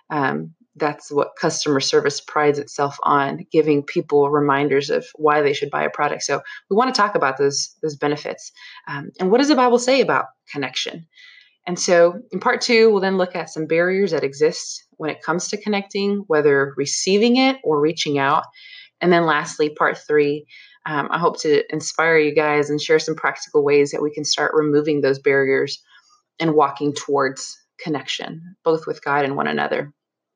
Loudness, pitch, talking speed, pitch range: -19 LUFS, 160 Hz, 185 wpm, 145-230 Hz